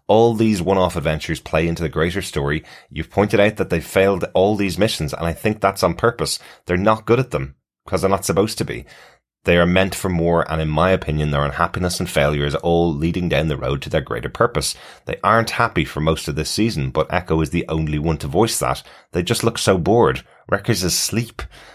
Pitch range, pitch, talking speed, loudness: 80-100 Hz, 85 Hz, 235 wpm, -19 LUFS